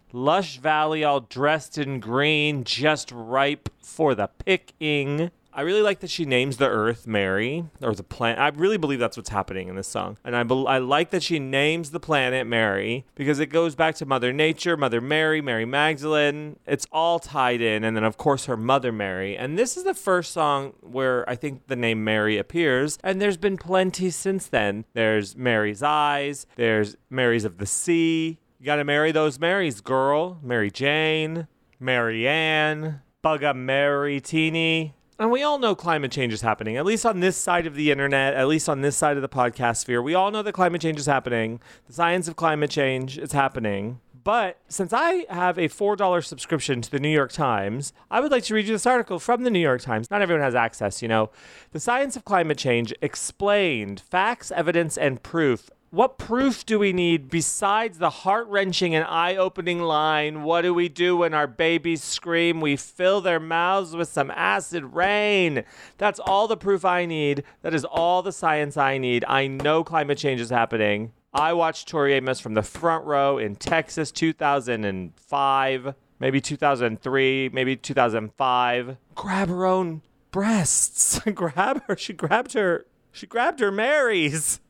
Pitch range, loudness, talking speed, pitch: 125-170 Hz, -23 LUFS, 185 wpm, 150 Hz